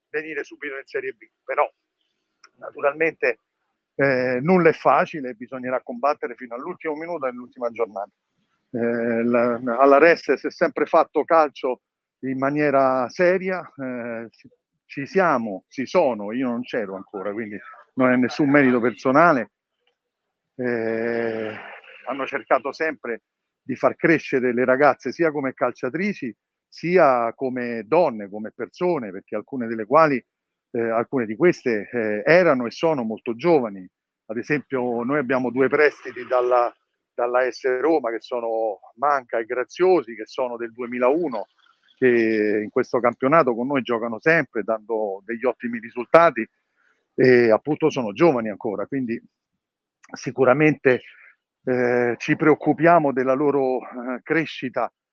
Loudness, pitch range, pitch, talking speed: -21 LUFS, 120-150 Hz, 130 Hz, 130 wpm